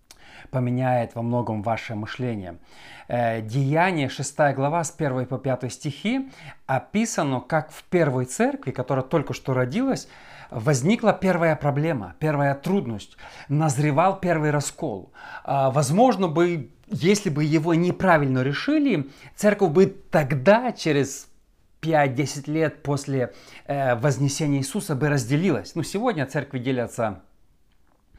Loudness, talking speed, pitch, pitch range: -23 LUFS, 115 wpm, 145 Hz, 130-170 Hz